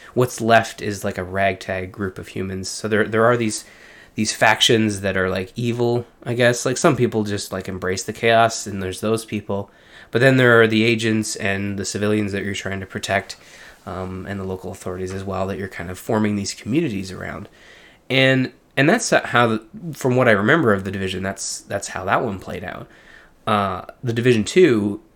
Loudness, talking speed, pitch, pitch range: -20 LUFS, 205 wpm, 105 Hz, 95-115 Hz